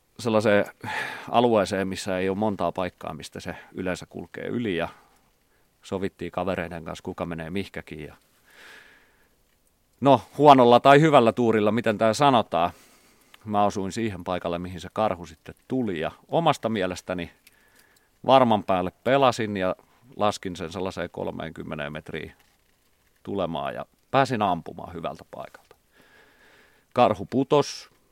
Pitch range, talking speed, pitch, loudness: 90-115 Hz, 120 wpm, 95 Hz, -24 LUFS